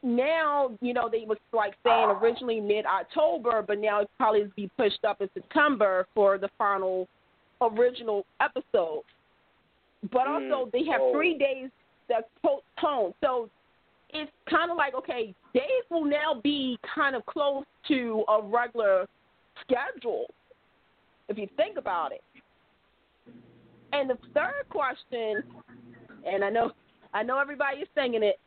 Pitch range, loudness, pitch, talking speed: 210-295 Hz, -28 LUFS, 245 Hz, 140 wpm